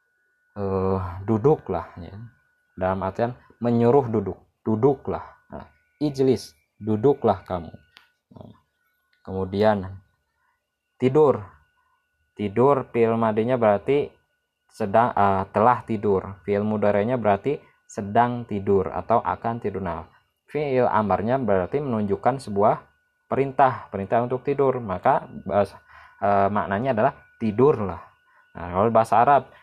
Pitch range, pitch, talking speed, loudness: 100-140 Hz, 110 Hz, 100 wpm, -23 LUFS